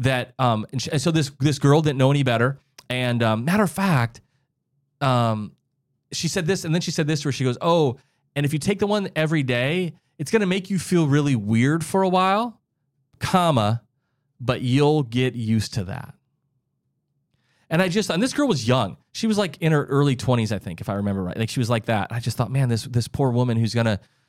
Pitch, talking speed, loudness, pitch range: 140 Hz, 225 wpm, -22 LUFS, 125-160 Hz